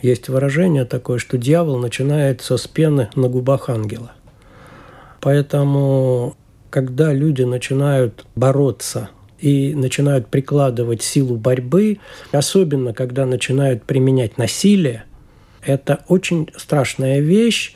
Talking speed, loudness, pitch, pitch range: 100 wpm, -17 LUFS, 135 Hz, 125-145 Hz